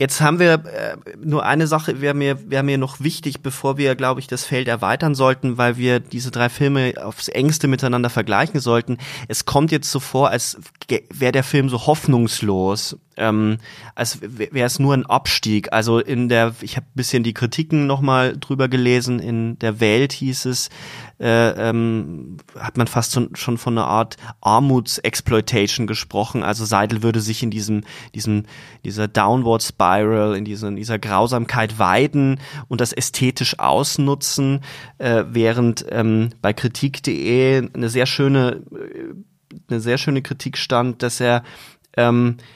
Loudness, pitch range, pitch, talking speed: -19 LUFS, 115-135 Hz, 125 Hz, 160 wpm